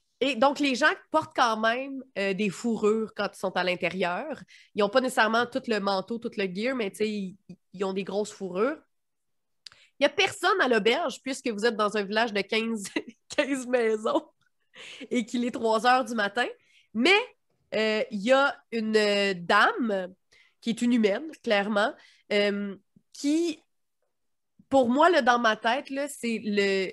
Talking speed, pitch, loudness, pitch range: 175 wpm, 225 Hz, -26 LUFS, 205-265 Hz